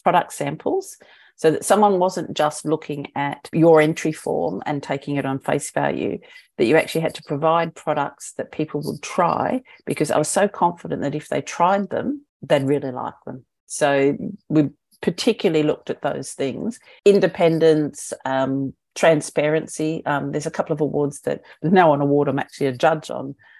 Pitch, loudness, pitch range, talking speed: 155 Hz, -21 LUFS, 145-180 Hz, 175 wpm